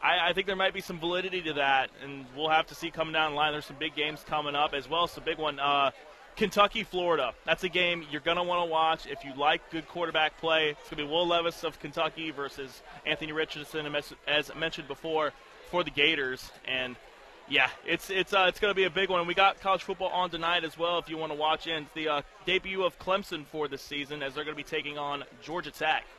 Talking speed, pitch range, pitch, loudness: 245 wpm, 150-175 Hz, 160 Hz, -29 LUFS